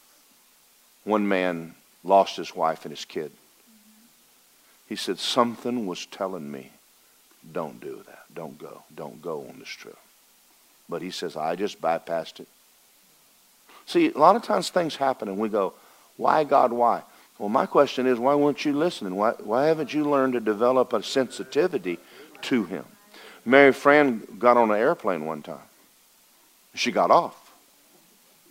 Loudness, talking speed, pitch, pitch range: -24 LUFS, 155 wpm, 135 Hz, 110-150 Hz